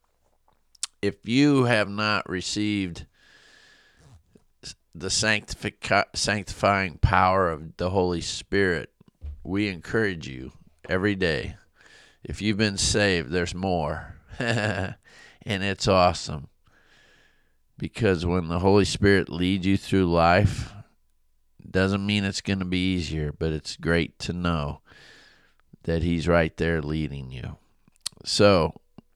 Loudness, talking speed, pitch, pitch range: -24 LUFS, 115 wpm, 95 Hz, 80-100 Hz